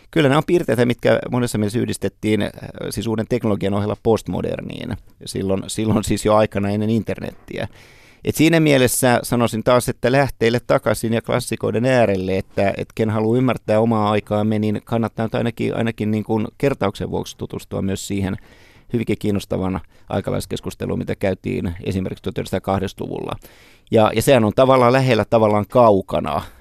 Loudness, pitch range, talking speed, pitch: -19 LUFS, 100-120 Hz, 145 wpm, 110 Hz